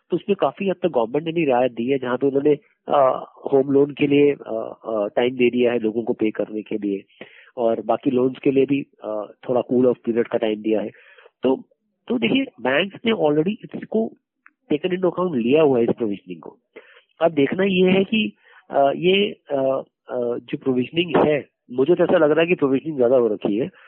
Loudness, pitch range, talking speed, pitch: -21 LUFS, 120-180 Hz, 215 wpm, 140 Hz